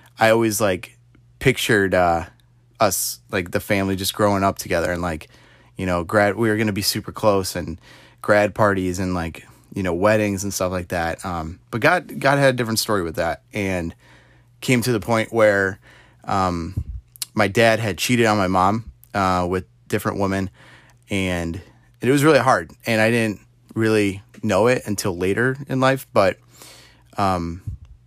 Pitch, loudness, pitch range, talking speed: 105 Hz, -20 LUFS, 90-115 Hz, 175 wpm